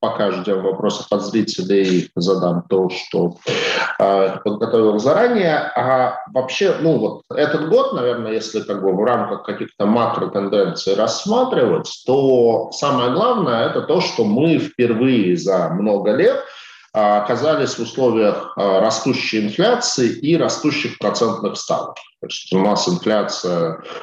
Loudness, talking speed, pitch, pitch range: -18 LUFS, 125 wpm, 110 Hz, 95-125 Hz